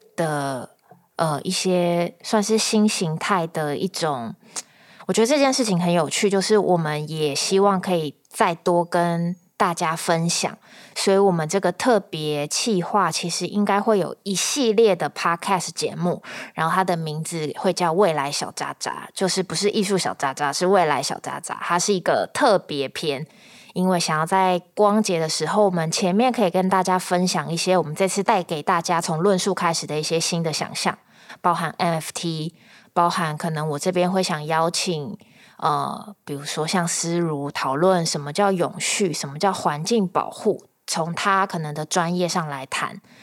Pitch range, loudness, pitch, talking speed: 160-195 Hz, -22 LUFS, 180 Hz, 265 characters per minute